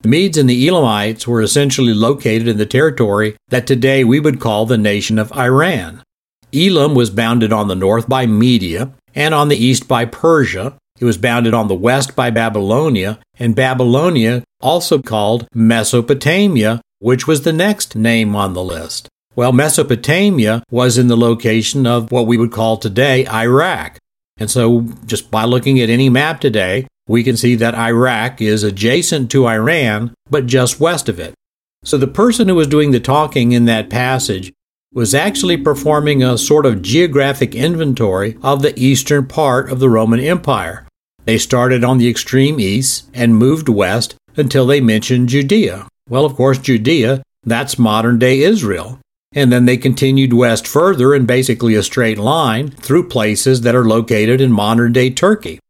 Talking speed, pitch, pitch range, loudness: 170 wpm, 125 Hz, 115-135 Hz, -13 LUFS